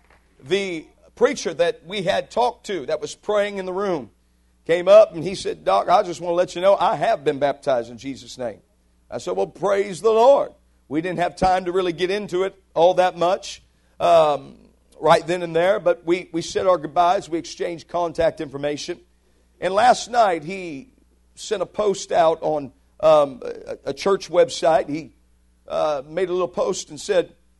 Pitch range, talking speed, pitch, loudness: 140-195 Hz, 190 wpm, 175 Hz, -21 LUFS